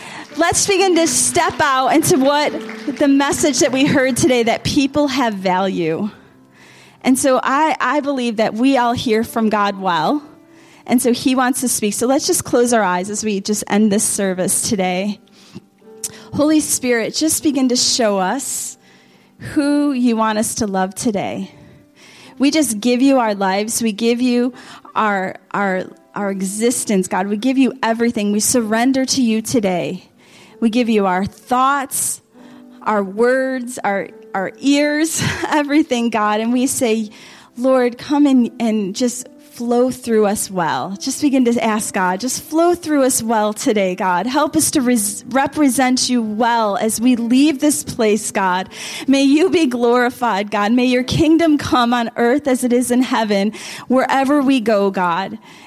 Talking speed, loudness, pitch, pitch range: 165 wpm, -16 LUFS, 240 Hz, 210-270 Hz